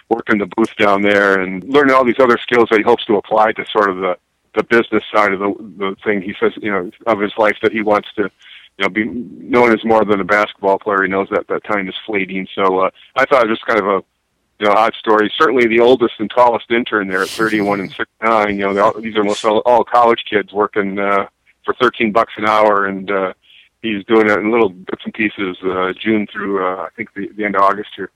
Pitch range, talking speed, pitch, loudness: 100-110 Hz, 255 wpm, 105 Hz, -15 LUFS